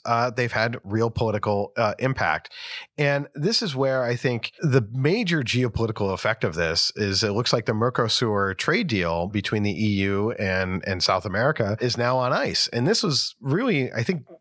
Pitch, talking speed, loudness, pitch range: 115 Hz, 185 wpm, -23 LUFS, 105-130 Hz